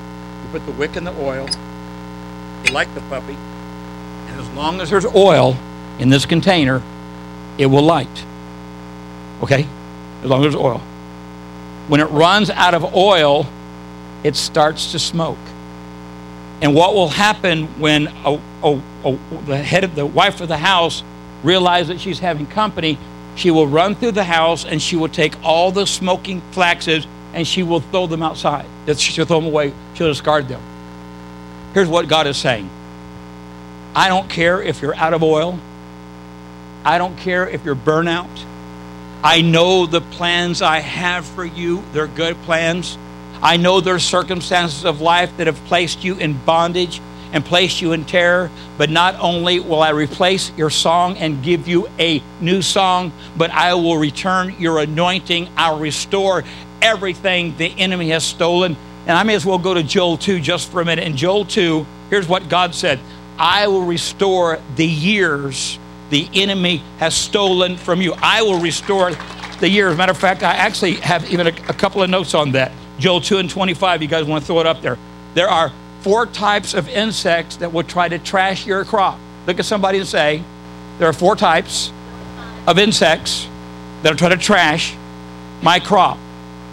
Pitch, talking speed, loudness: 160 Hz, 175 wpm, -16 LUFS